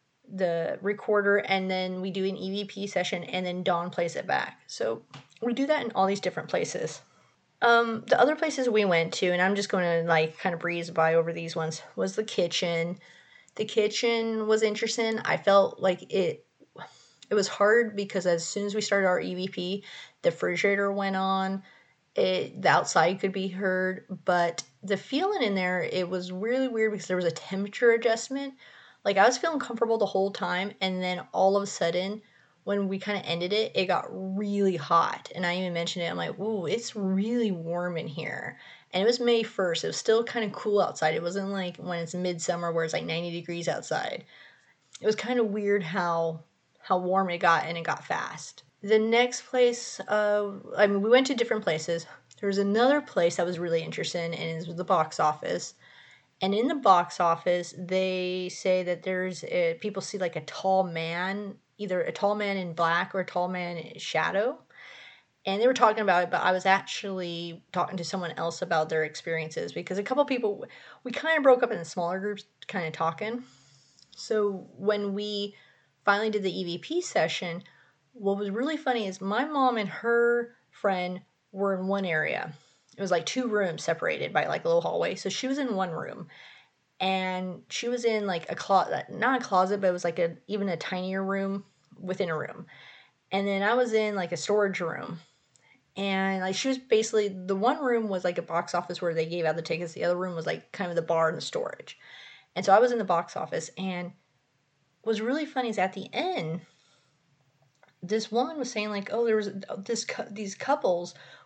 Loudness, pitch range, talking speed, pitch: -28 LUFS, 175-215 Hz, 205 wpm, 190 Hz